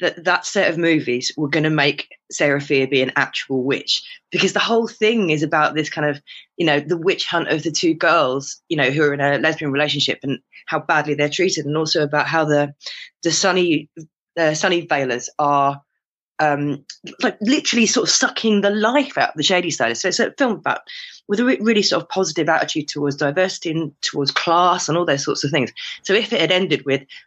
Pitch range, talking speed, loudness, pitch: 145-190 Hz, 220 wpm, -18 LUFS, 160 Hz